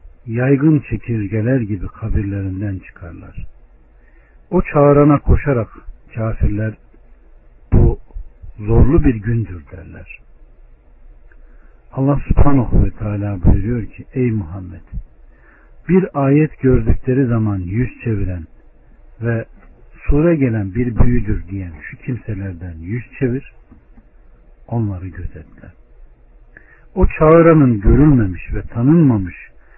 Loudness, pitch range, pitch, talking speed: -16 LUFS, 90-125 Hz, 105 Hz, 90 wpm